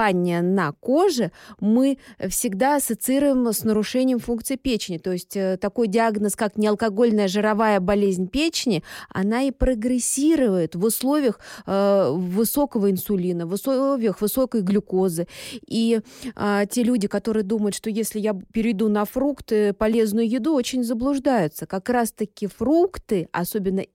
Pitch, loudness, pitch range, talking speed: 220 Hz, -22 LUFS, 200-250 Hz, 125 wpm